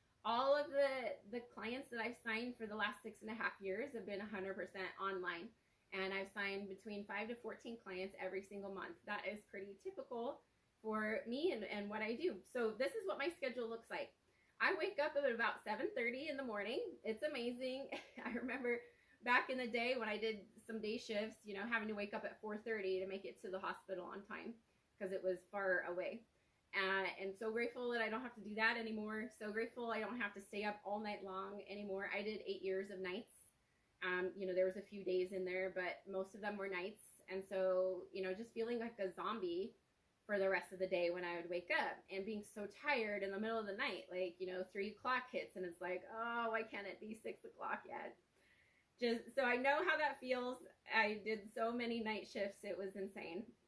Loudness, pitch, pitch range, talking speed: -43 LUFS, 210 Hz, 195-235 Hz, 230 wpm